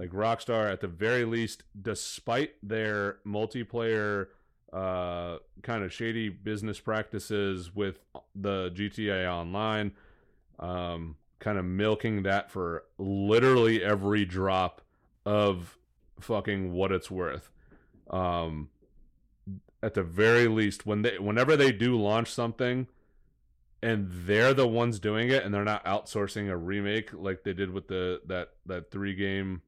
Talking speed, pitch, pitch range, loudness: 135 wpm, 105 Hz, 95-110 Hz, -29 LUFS